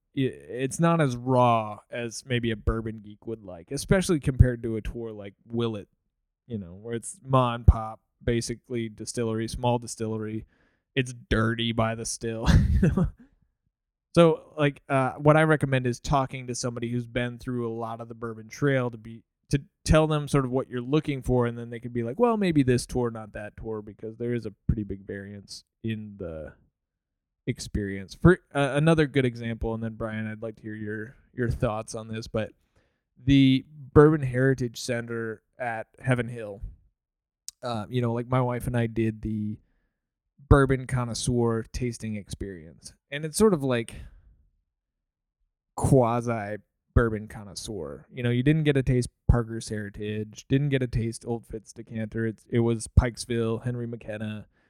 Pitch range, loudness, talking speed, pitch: 110-130 Hz, -27 LUFS, 170 wpm, 115 Hz